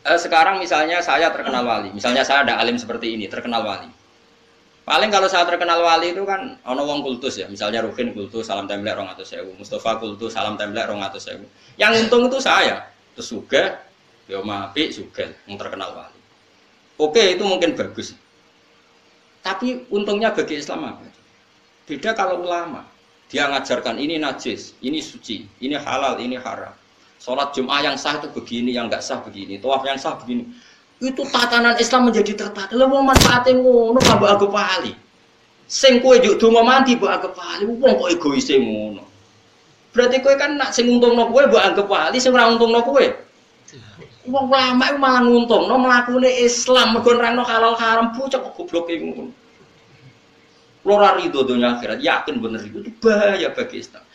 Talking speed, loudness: 170 wpm, -17 LUFS